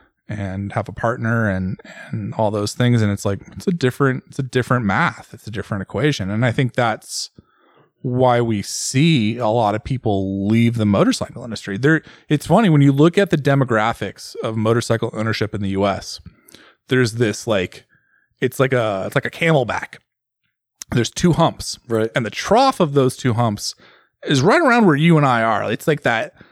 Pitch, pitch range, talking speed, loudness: 115 Hz, 105-140 Hz, 190 wpm, -18 LUFS